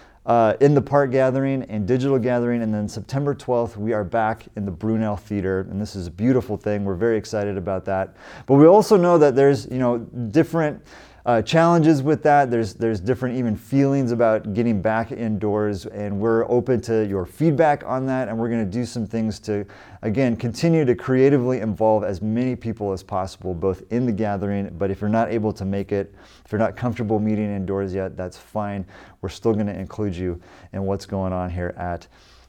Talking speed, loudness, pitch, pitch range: 205 wpm, -21 LUFS, 110 Hz, 100-125 Hz